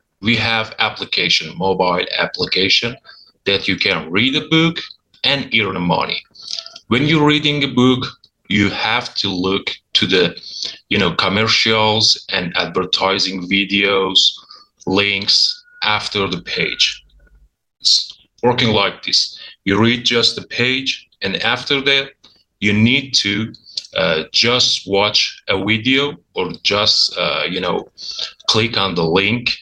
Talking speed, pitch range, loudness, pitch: 130 wpm, 100-135 Hz, -15 LUFS, 115 Hz